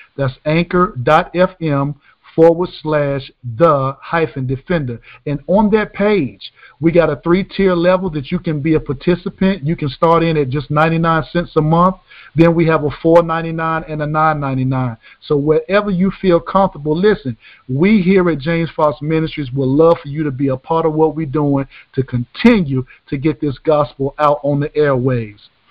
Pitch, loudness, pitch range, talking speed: 155 Hz, -15 LUFS, 140-170 Hz, 175 wpm